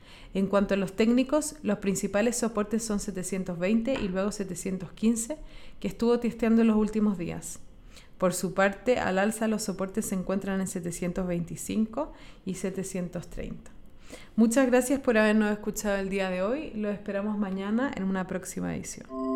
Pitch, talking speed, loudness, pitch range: 200 Hz, 150 wpm, -28 LUFS, 190-225 Hz